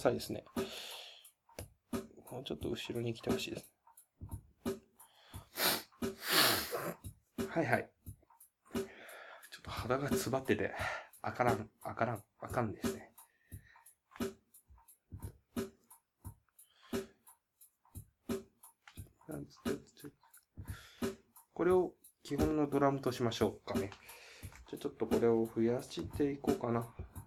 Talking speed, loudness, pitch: 185 characters per minute, -37 LUFS, 130 Hz